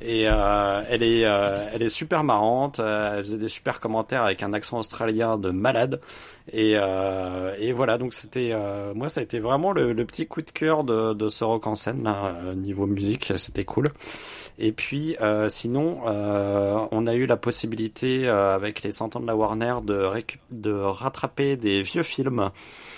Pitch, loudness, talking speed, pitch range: 110 Hz, -25 LUFS, 190 wpm, 100-120 Hz